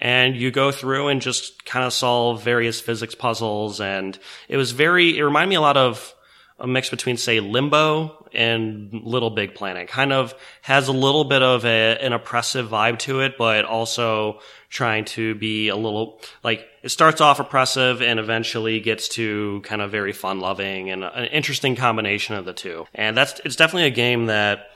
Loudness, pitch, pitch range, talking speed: -20 LUFS, 120 Hz, 110-135 Hz, 190 wpm